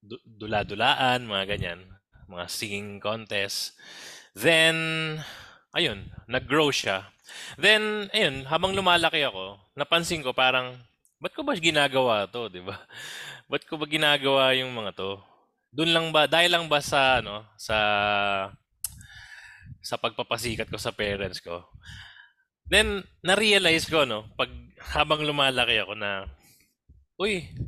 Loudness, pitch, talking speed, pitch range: -24 LUFS, 120 Hz, 125 wpm, 100-155 Hz